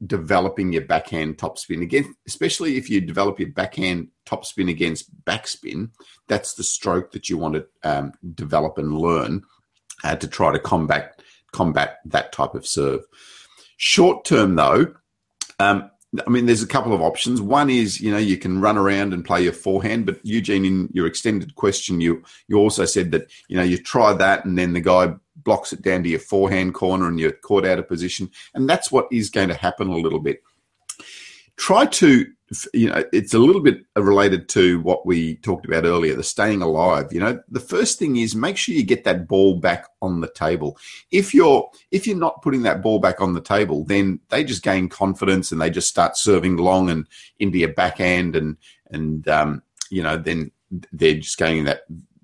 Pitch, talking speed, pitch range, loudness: 95 Hz, 195 wpm, 85-100 Hz, -20 LUFS